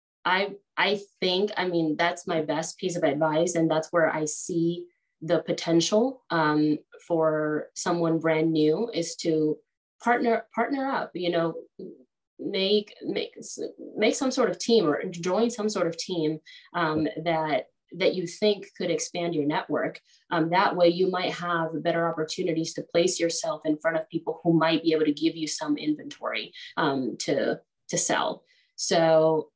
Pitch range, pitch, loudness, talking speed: 160-200 Hz, 170 Hz, -26 LUFS, 165 wpm